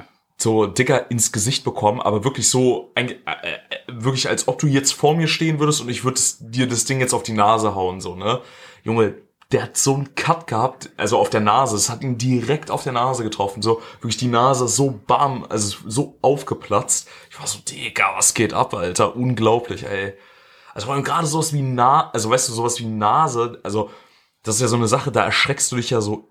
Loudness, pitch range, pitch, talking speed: -19 LUFS, 110-135 Hz, 120 Hz, 210 wpm